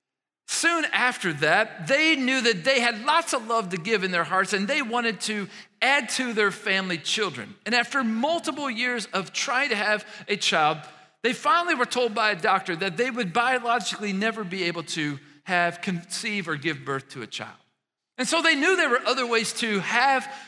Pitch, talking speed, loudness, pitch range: 220 Hz, 200 wpm, -24 LUFS, 190-255 Hz